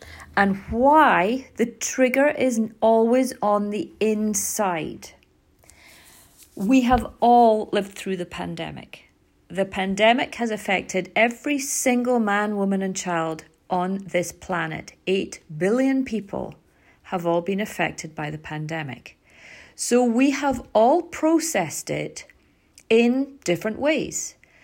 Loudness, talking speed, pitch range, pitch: -22 LUFS, 115 wpm, 185-250 Hz, 215 Hz